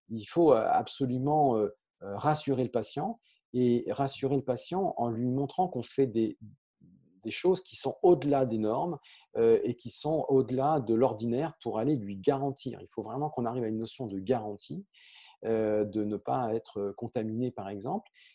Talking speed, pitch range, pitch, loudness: 165 wpm, 110-145 Hz, 125 Hz, -30 LUFS